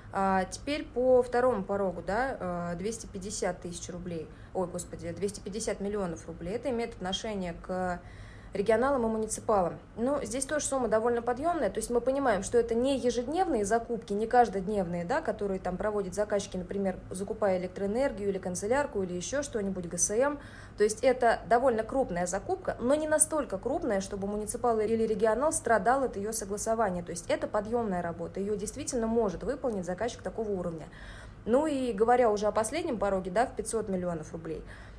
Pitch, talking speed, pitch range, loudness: 215 Hz, 160 wpm, 185-245 Hz, -30 LUFS